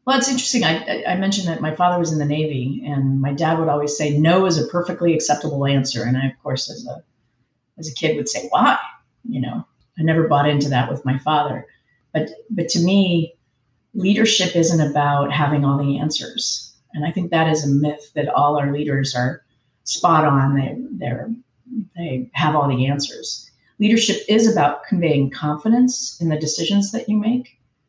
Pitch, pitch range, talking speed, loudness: 150 Hz, 140-175 Hz, 195 wpm, -19 LUFS